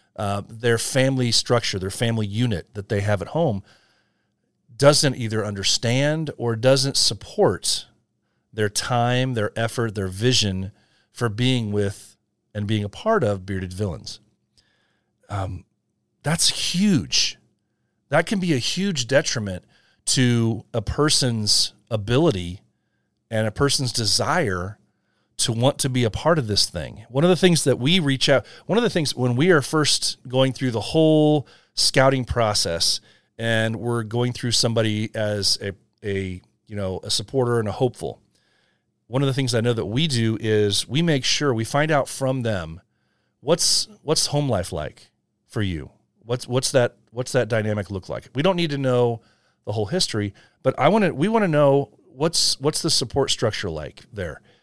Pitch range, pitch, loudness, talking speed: 105-140 Hz, 115 Hz, -21 LUFS, 170 wpm